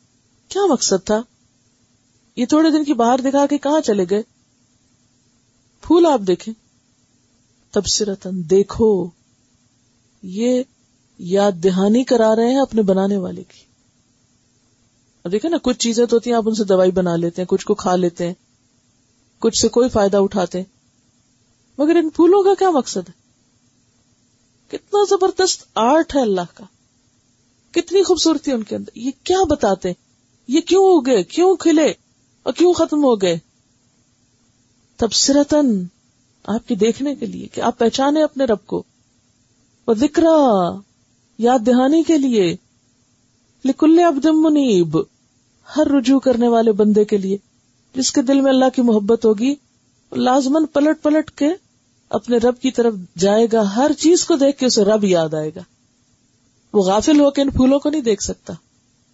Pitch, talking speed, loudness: 210 Hz, 150 wpm, -16 LUFS